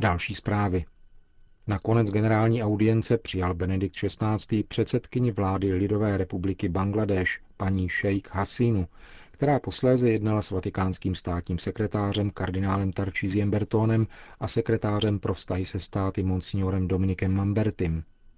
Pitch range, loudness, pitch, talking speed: 95-110 Hz, -26 LUFS, 100 Hz, 115 wpm